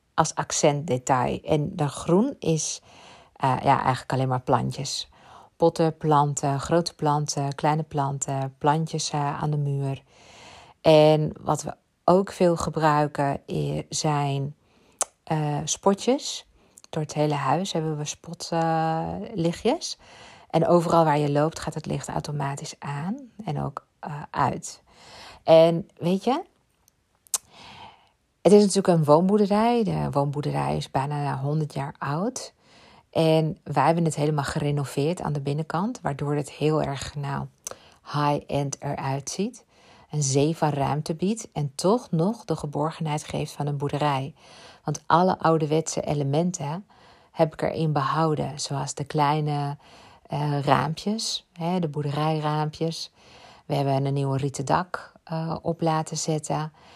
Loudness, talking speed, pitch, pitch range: -25 LUFS, 135 wpm, 150 Hz, 145-165 Hz